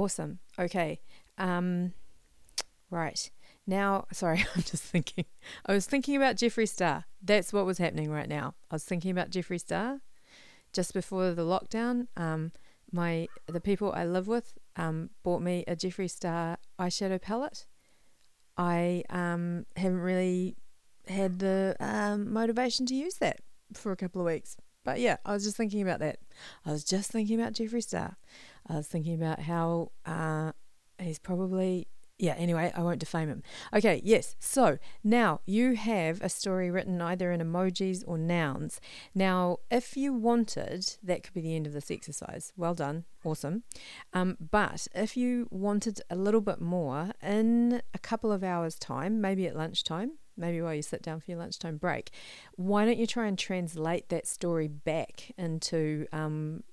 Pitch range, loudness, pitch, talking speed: 170-205 Hz, -32 LUFS, 180 Hz, 165 wpm